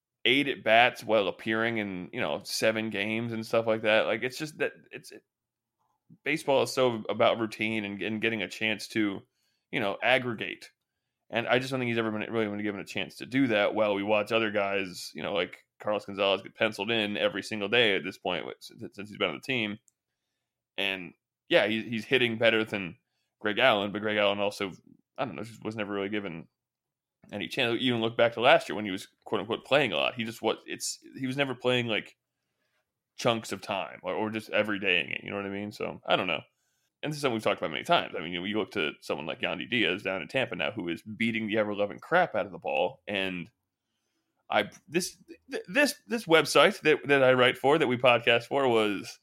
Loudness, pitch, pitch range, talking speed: -28 LUFS, 110 Hz, 105-120 Hz, 235 wpm